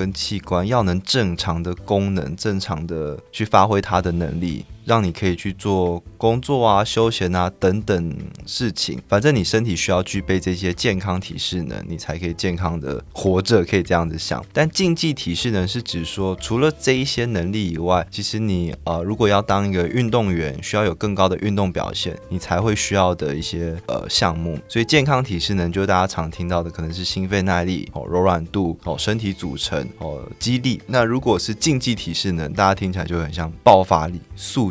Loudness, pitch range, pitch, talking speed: -20 LUFS, 85-105 Hz, 95 Hz, 300 characters per minute